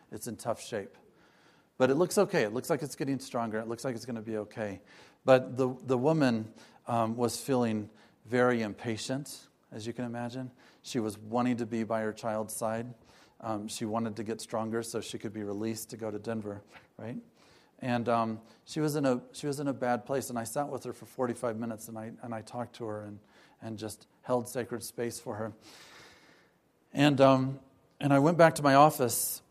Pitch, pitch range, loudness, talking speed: 120 Hz, 110-130 Hz, -31 LUFS, 210 wpm